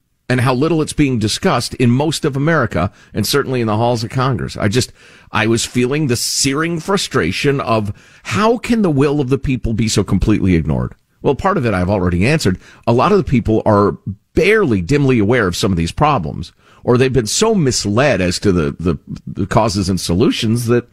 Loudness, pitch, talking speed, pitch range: -15 LUFS, 120 Hz, 205 wpm, 105-140 Hz